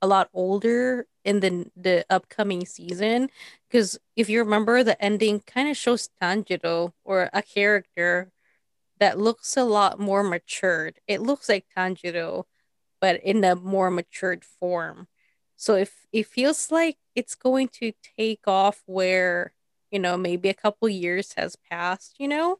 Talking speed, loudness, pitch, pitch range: 155 wpm, -24 LUFS, 200 Hz, 185-225 Hz